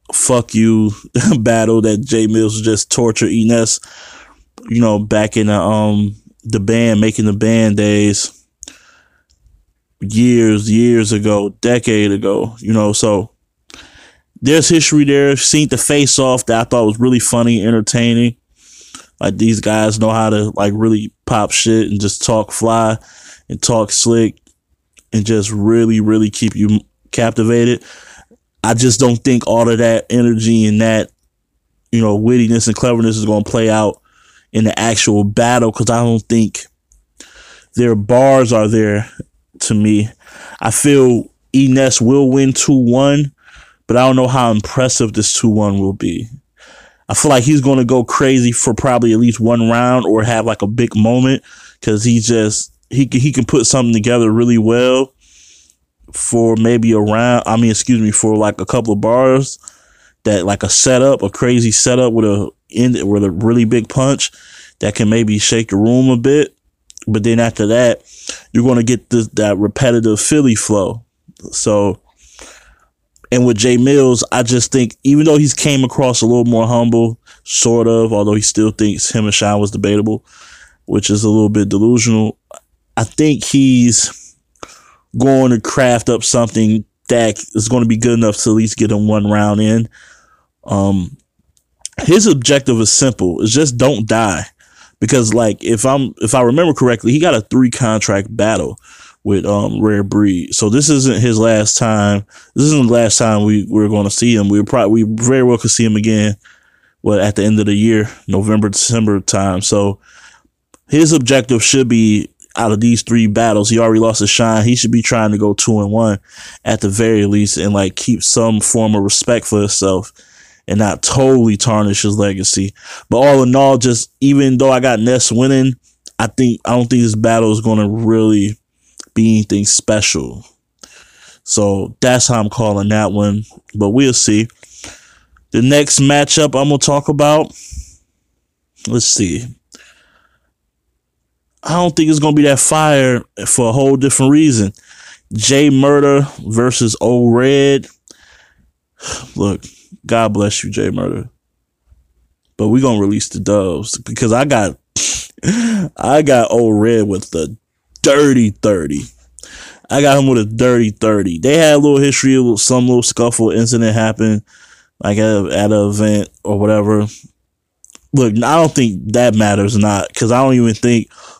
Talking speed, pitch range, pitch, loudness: 170 wpm, 105-125 Hz, 115 Hz, -12 LUFS